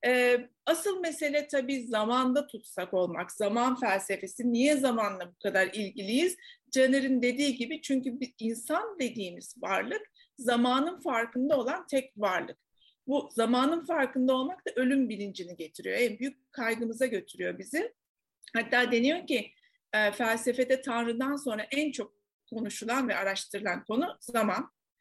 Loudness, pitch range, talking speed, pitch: -30 LUFS, 225-280 Hz, 125 wpm, 250 Hz